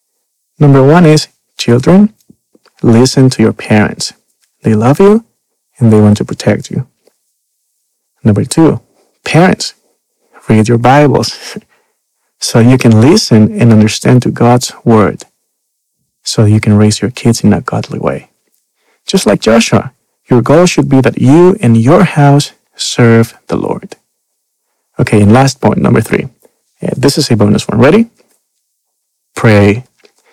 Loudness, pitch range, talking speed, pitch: -8 LUFS, 110-145 Hz, 140 wpm, 120 Hz